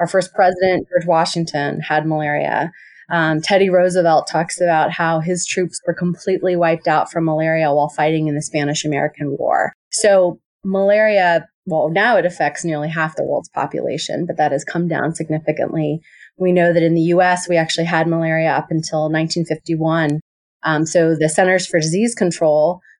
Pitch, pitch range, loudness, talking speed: 165 Hz, 155-180 Hz, -17 LUFS, 170 wpm